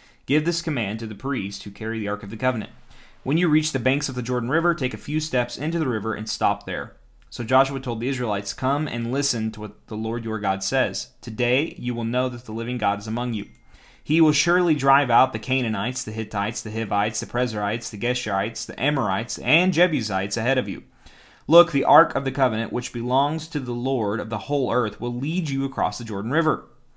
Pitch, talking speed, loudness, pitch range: 120 Hz, 225 wpm, -23 LUFS, 110-140 Hz